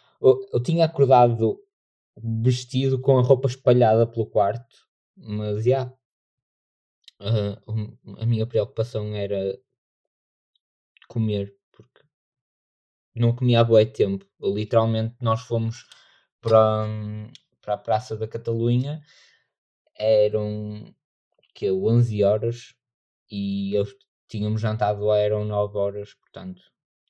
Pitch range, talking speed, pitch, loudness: 105-125 Hz, 110 wpm, 110 Hz, -23 LUFS